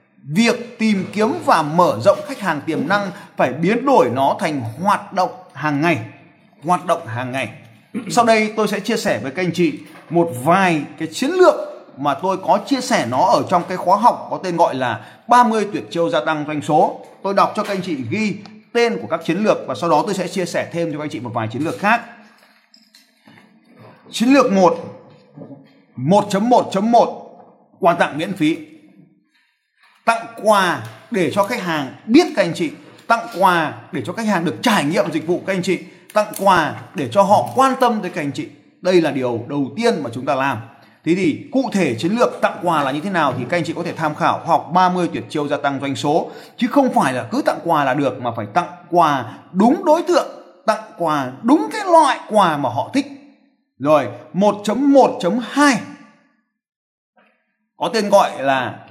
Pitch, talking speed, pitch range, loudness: 190 Hz, 205 wpm, 160-230 Hz, -18 LUFS